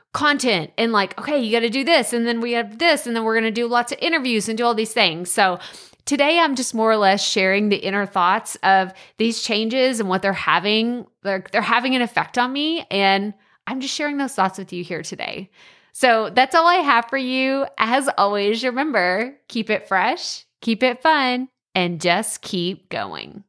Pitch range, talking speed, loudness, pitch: 200-260 Hz, 215 wpm, -19 LUFS, 230 Hz